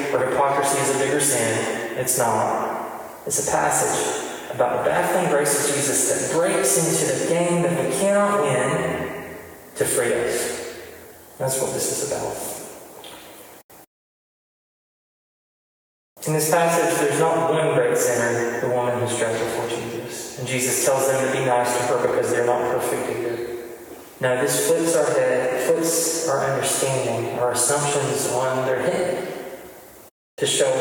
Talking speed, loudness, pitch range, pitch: 140 wpm, -21 LUFS, 125-180 Hz, 145 Hz